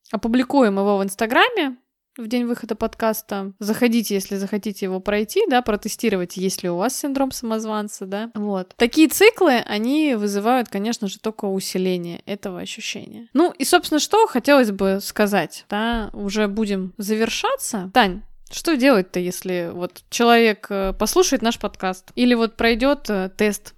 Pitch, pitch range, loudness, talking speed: 220 Hz, 200-245 Hz, -20 LUFS, 140 wpm